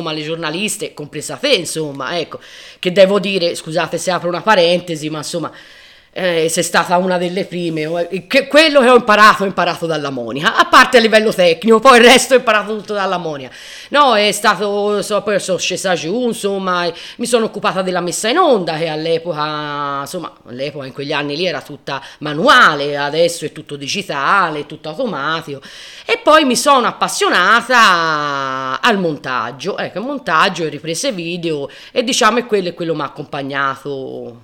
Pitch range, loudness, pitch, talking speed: 155-210 Hz, -14 LUFS, 175 Hz, 175 wpm